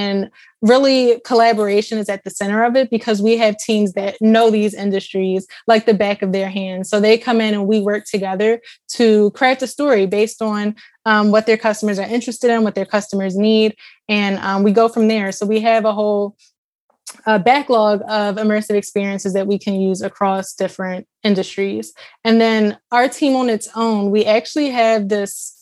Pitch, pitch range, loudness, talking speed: 215 Hz, 200-225 Hz, -16 LUFS, 190 wpm